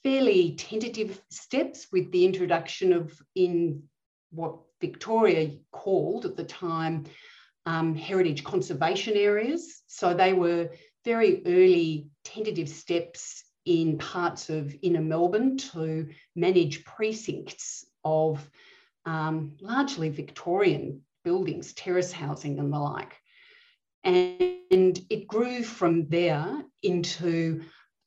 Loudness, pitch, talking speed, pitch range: -27 LUFS, 175 Hz, 105 wpm, 160-215 Hz